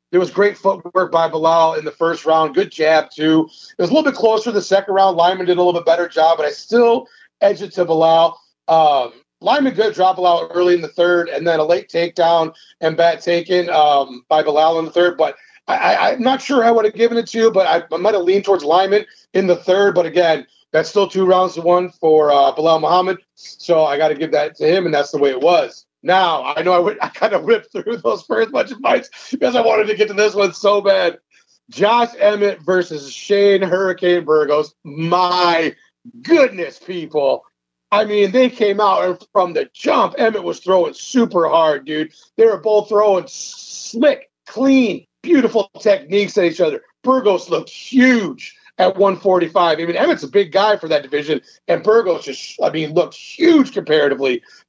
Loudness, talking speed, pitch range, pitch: -16 LUFS, 210 wpm, 165-215 Hz, 185 Hz